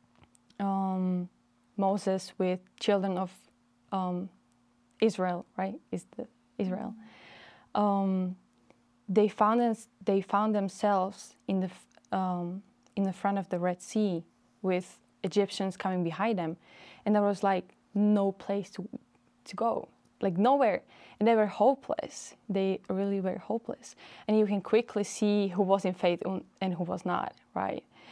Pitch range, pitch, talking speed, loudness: 185-210 Hz, 195 Hz, 145 wpm, -31 LUFS